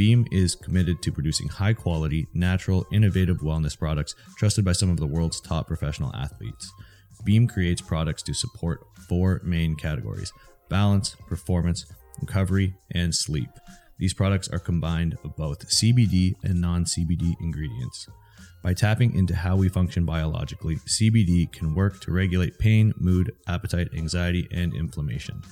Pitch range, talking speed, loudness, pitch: 85-100 Hz, 145 wpm, -25 LUFS, 90 Hz